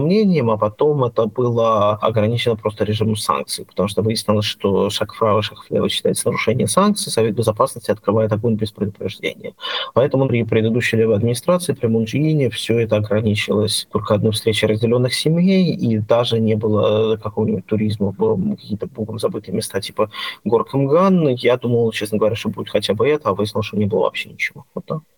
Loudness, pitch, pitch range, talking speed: -18 LUFS, 110 Hz, 110-125 Hz, 165 wpm